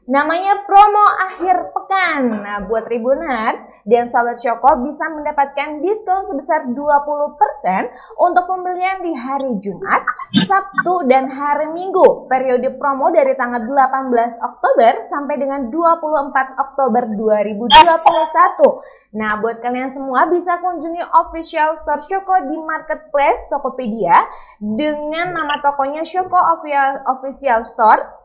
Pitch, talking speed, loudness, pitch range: 290 Hz, 115 wpm, -16 LUFS, 255-335 Hz